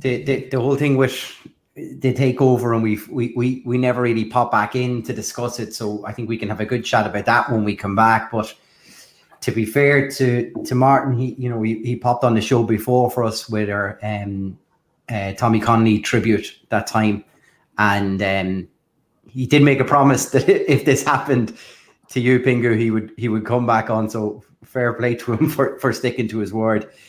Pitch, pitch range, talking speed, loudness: 120 Hz, 110-130 Hz, 215 wpm, -19 LUFS